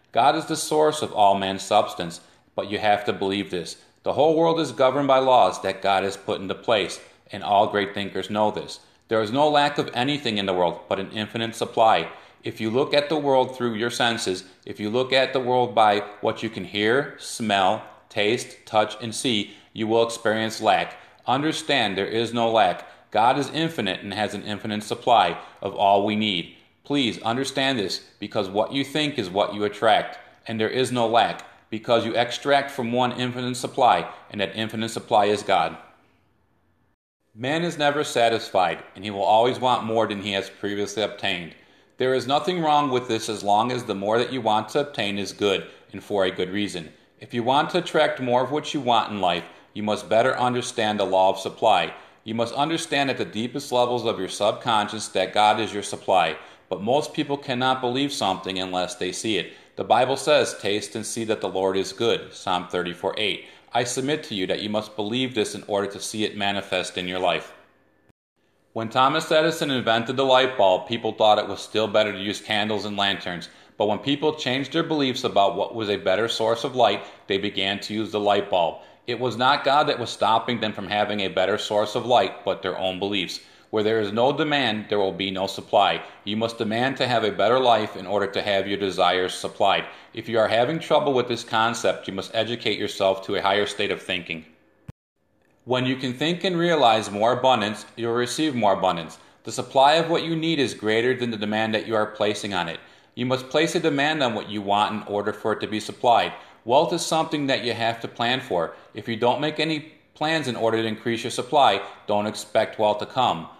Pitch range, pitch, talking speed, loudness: 100-130 Hz, 110 Hz, 215 wpm, -23 LUFS